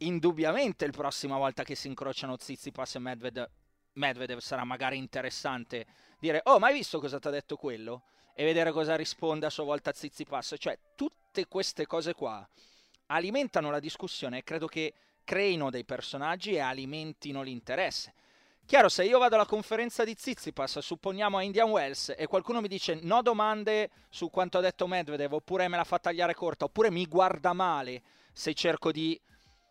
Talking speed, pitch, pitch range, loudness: 180 wpm, 160 Hz, 135-190 Hz, -31 LUFS